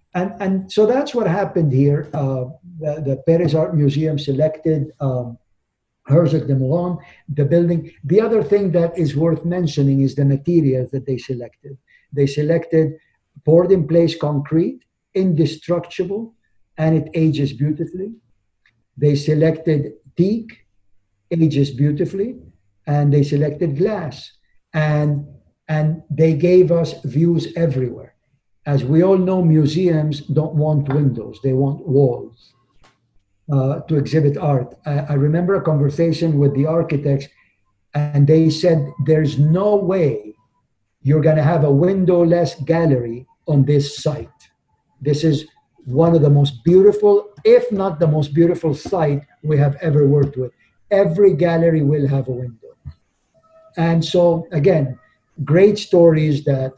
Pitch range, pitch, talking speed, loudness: 140-170 Hz, 155 Hz, 135 wpm, -17 LUFS